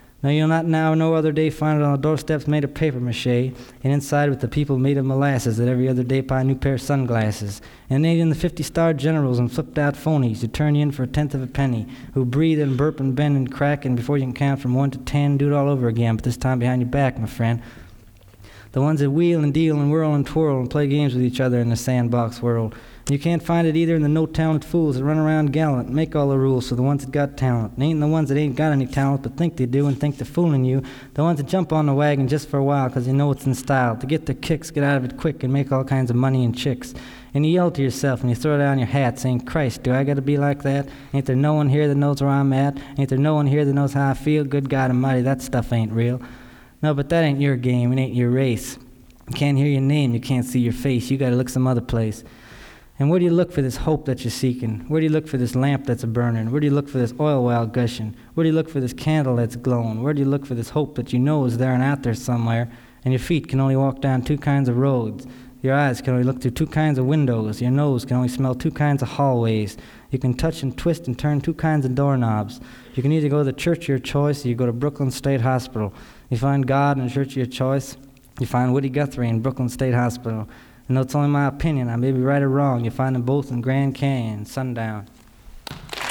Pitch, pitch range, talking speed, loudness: 135 Hz, 125-145 Hz, 280 wpm, -21 LUFS